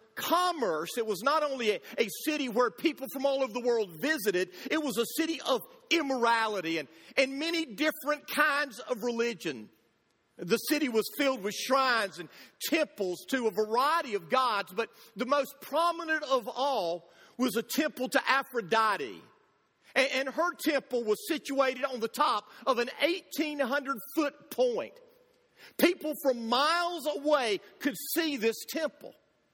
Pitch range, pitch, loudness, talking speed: 230-305 Hz, 270 Hz, -30 LUFS, 150 wpm